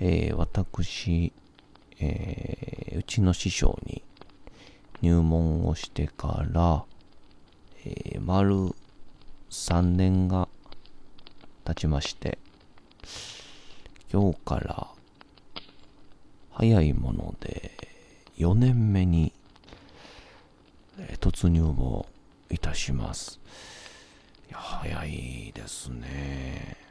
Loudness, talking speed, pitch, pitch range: -28 LUFS, 120 characters per minute, 85 Hz, 75-95 Hz